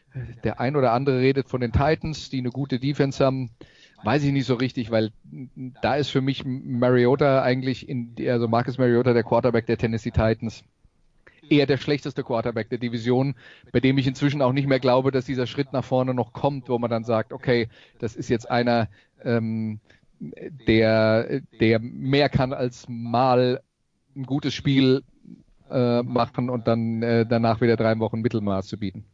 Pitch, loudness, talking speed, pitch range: 125 Hz, -23 LUFS, 180 wpm, 115-135 Hz